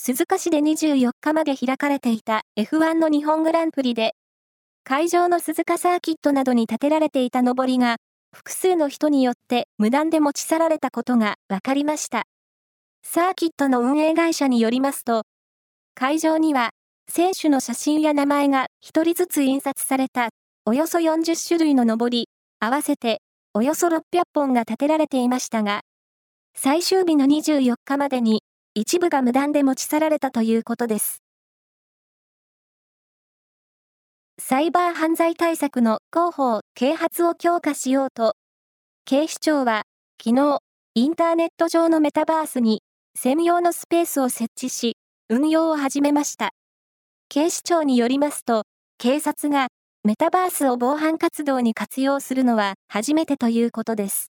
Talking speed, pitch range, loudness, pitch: 295 characters per minute, 245-320 Hz, -21 LUFS, 280 Hz